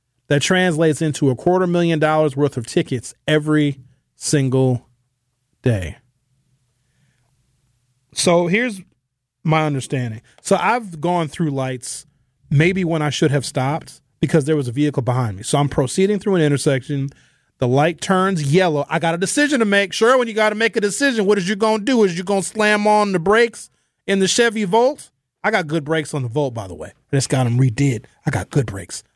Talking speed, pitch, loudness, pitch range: 190 wpm, 150 Hz, -18 LUFS, 130-185 Hz